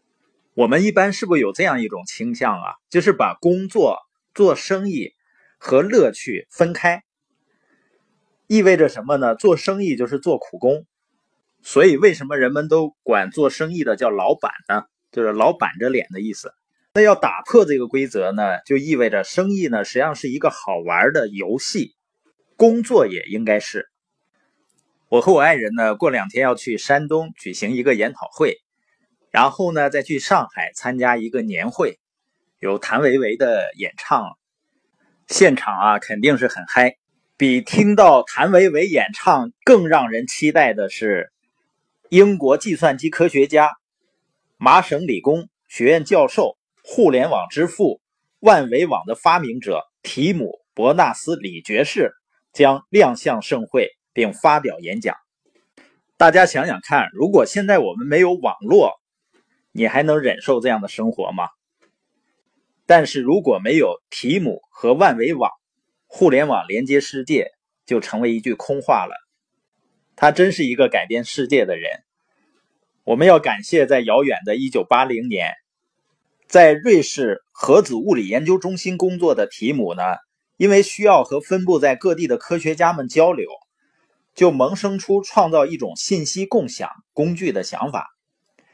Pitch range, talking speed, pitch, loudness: 145-210 Hz, 225 characters per minute, 180 Hz, -17 LUFS